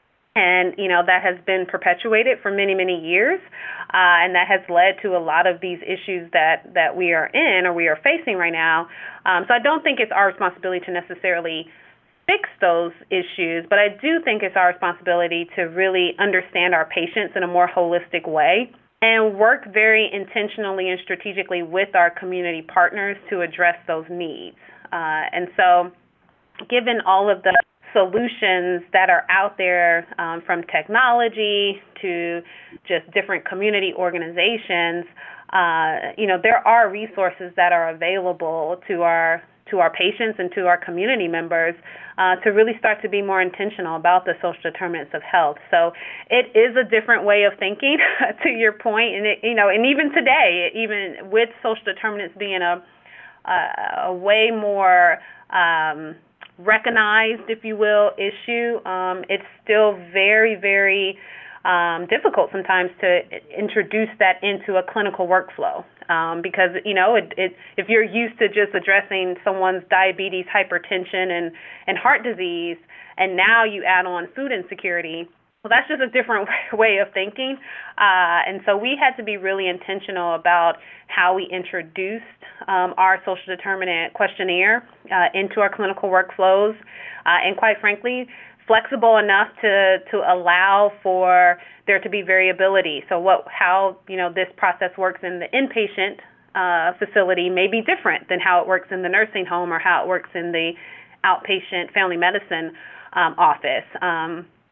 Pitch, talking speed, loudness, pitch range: 190 Hz, 165 wpm, -19 LUFS, 180-210 Hz